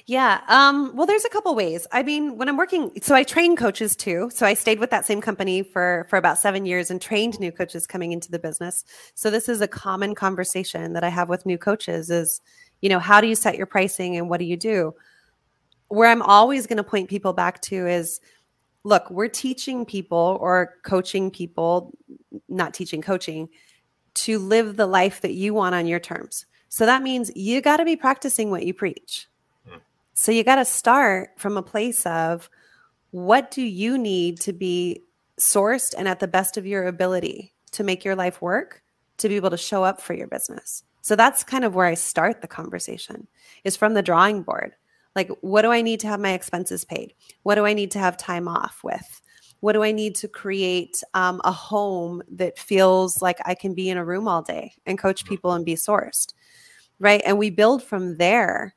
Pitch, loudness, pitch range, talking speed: 195 Hz, -21 LUFS, 180-225 Hz, 210 wpm